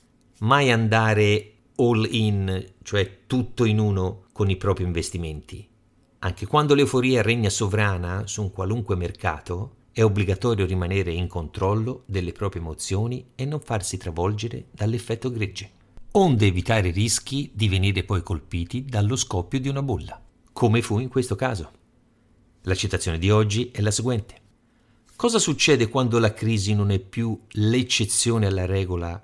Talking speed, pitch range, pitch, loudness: 145 wpm, 95-120 Hz, 110 Hz, -23 LUFS